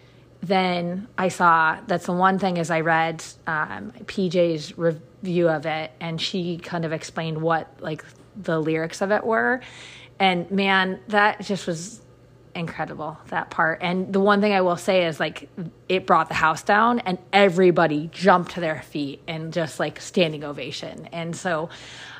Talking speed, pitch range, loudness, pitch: 170 wpm, 160-185 Hz, -23 LUFS, 170 Hz